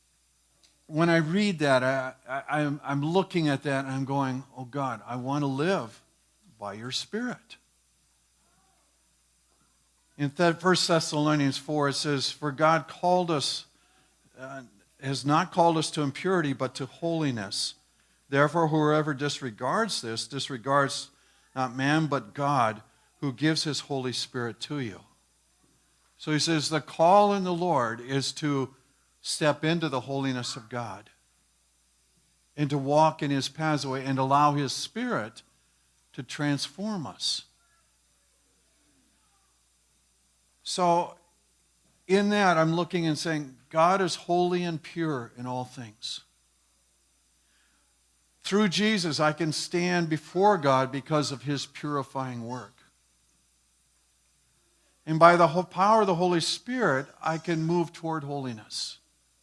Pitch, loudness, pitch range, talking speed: 140 Hz, -27 LUFS, 120-160 Hz, 130 wpm